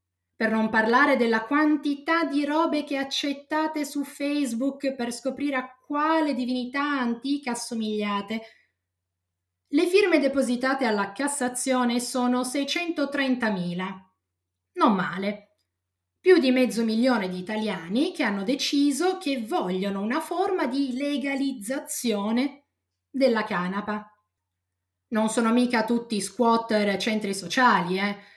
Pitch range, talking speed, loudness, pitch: 205-280 Hz, 110 wpm, -25 LUFS, 245 Hz